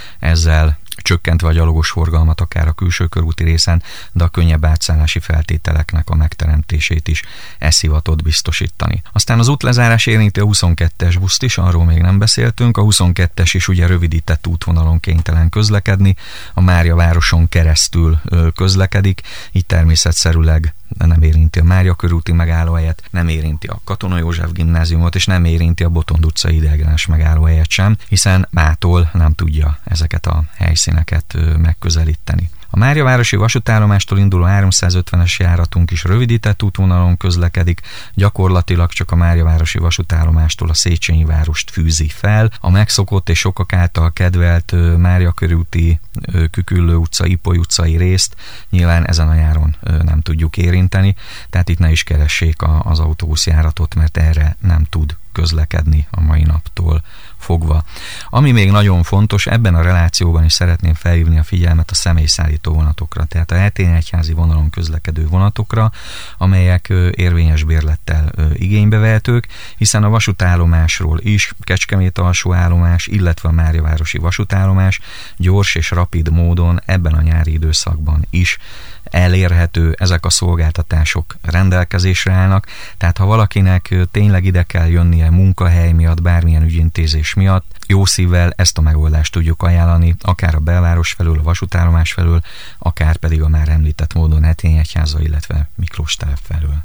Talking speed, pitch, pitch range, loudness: 140 wpm, 85 Hz, 80-95 Hz, -14 LUFS